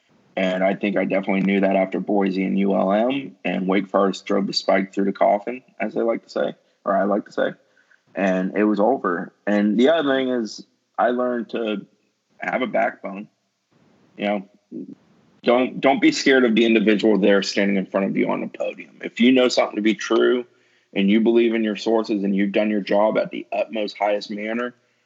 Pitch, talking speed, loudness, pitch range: 105 Hz, 205 wpm, -21 LUFS, 100-115 Hz